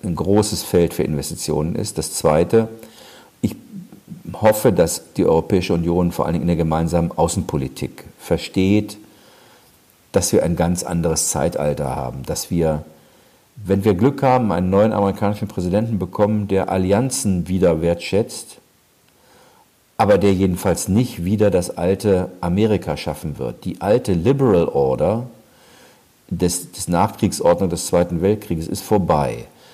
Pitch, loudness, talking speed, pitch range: 95 Hz, -19 LUFS, 130 wpm, 85-105 Hz